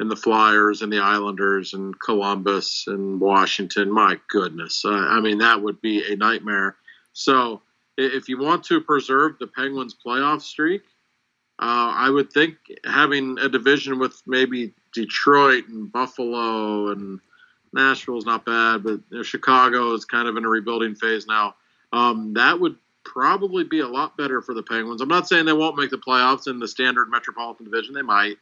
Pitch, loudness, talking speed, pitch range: 120 Hz, -20 LUFS, 175 wpm, 110-135 Hz